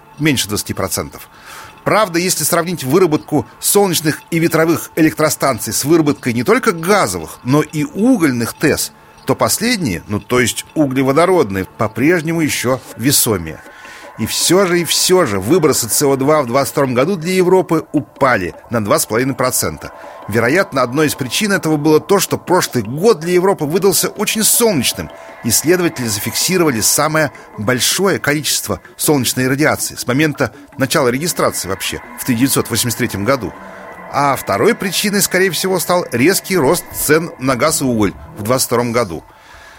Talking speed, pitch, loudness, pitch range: 135 wpm, 145 Hz, -14 LUFS, 120-175 Hz